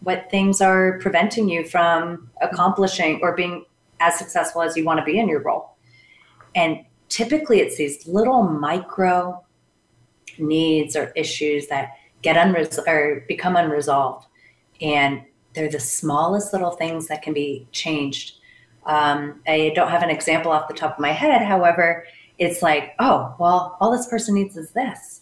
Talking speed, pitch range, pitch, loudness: 160 wpm, 145-180 Hz, 165 Hz, -20 LUFS